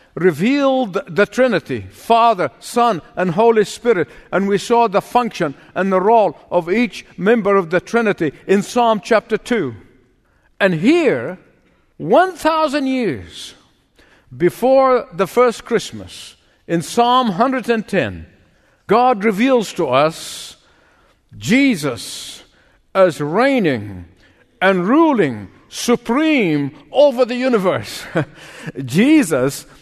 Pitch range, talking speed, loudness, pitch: 165-245 Hz, 105 wpm, -16 LUFS, 205 Hz